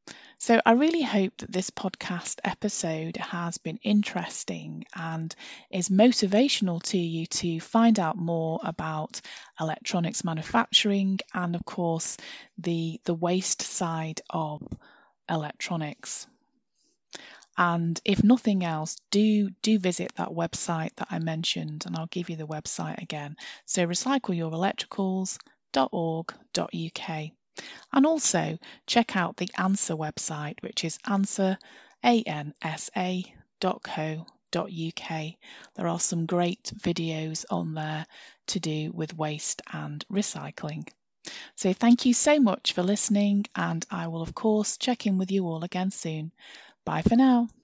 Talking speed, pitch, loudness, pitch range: 125 wpm, 180 Hz, -28 LUFS, 165-210 Hz